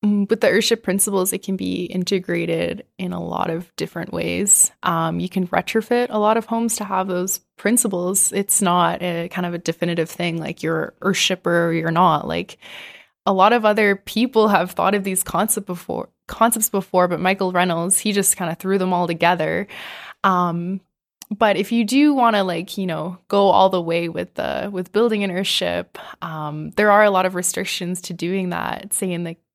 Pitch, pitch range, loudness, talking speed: 185 Hz, 175-205 Hz, -19 LUFS, 200 wpm